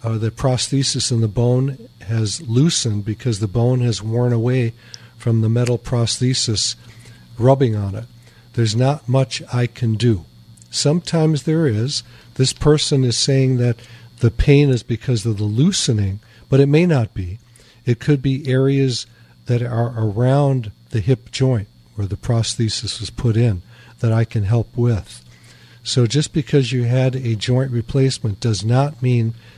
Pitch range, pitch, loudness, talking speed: 115-130 Hz, 120 Hz, -18 LUFS, 160 wpm